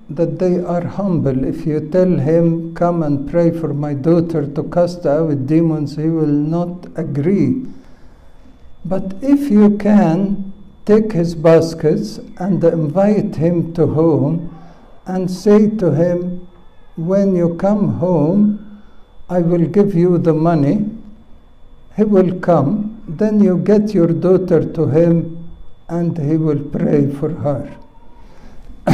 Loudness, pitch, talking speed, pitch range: -15 LUFS, 170 Hz, 135 wpm, 160-190 Hz